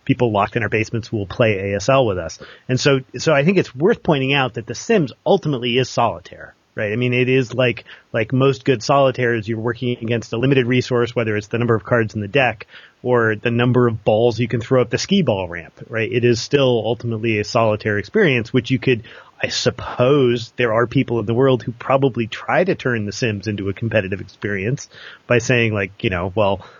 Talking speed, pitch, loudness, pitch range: 220 wpm, 120 Hz, -18 LUFS, 110-130 Hz